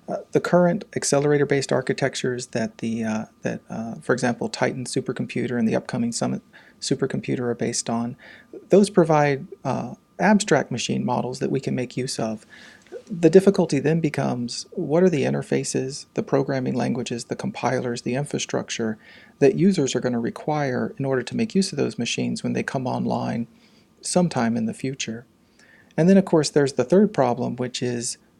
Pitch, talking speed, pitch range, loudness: 135 Hz, 175 wpm, 120-175 Hz, -23 LUFS